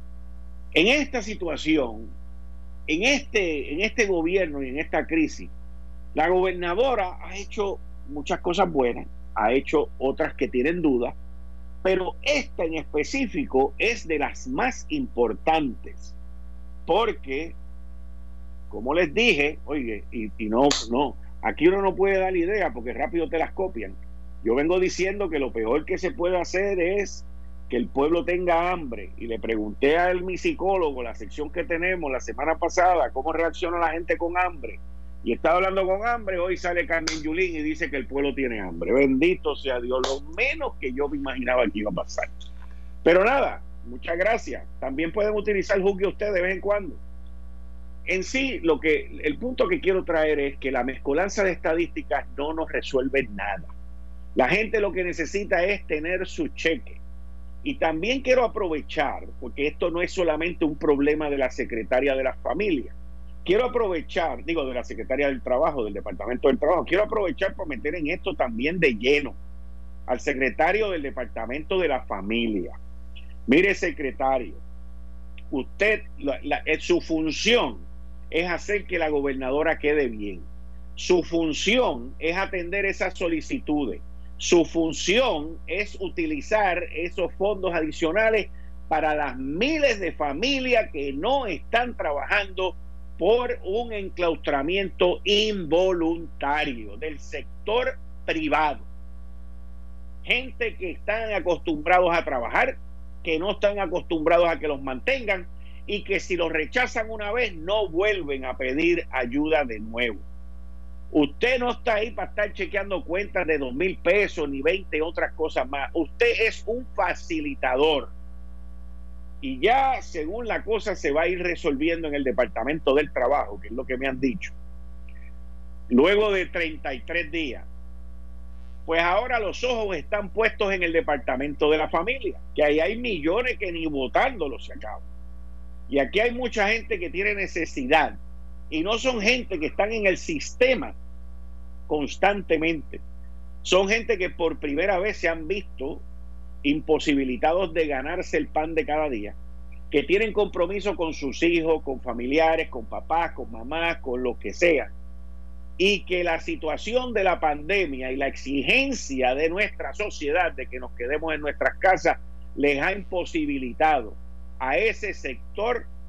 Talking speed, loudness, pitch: 150 wpm, -25 LUFS, 155 Hz